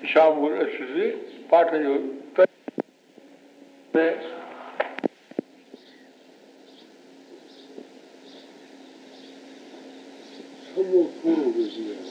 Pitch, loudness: 185 Hz, -24 LUFS